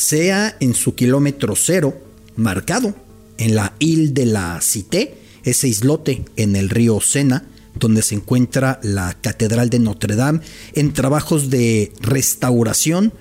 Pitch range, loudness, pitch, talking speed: 110-140 Hz, -17 LUFS, 120 Hz, 135 wpm